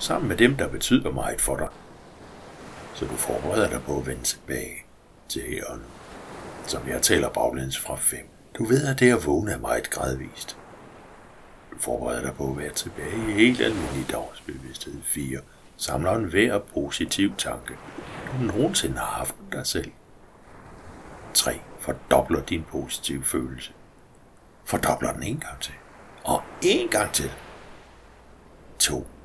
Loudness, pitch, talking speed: -25 LUFS, 70 Hz, 145 wpm